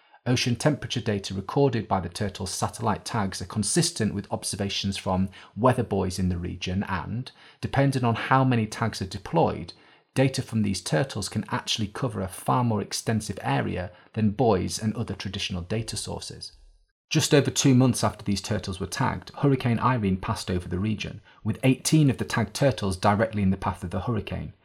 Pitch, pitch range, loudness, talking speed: 105 Hz, 95-120 Hz, -26 LUFS, 180 wpm